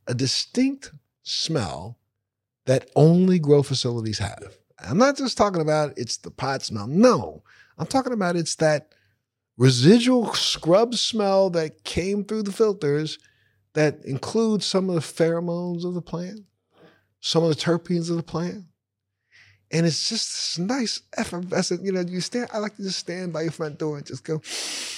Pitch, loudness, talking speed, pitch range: 165 Hz, -23 LUFS, 170 wpm, 130-195 Hz